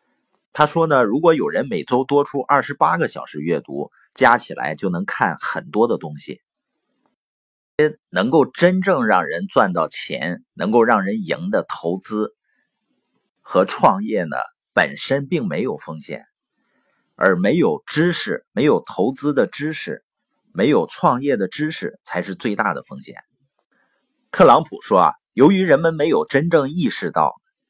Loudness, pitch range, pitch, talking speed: -19 LUFS, 110-165 Hz, 145 Hz, 215 characters per minute